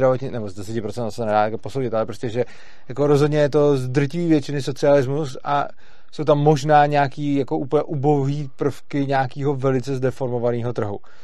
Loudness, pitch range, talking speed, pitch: -21 LUFS, 125-145 Hz, 160 wpm, 140 Hz